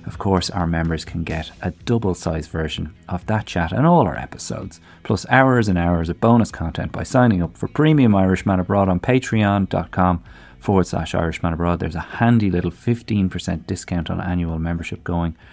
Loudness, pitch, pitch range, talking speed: -20 LUFS, 90 Hz, 85-110 Hz, 180 wpm